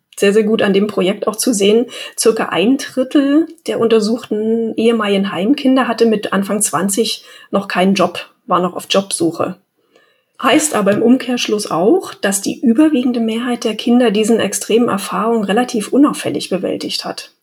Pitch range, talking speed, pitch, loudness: 200-245 Hz, 155 wpm, 225 Hz, -15 LUFS